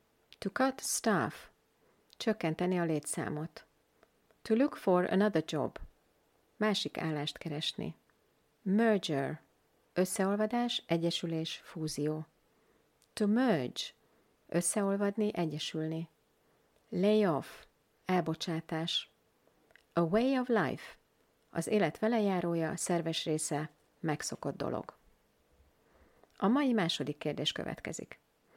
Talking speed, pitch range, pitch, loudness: 85 wpm, 155-210 Hz, 170 Hz, -33 LUFS